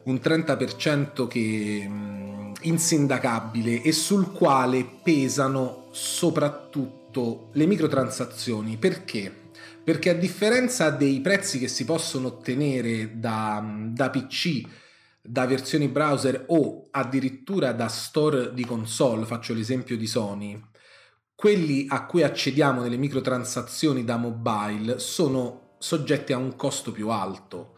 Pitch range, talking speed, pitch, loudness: 115-150 Hz, 115 wpm, 130 Hz, -25 LUFS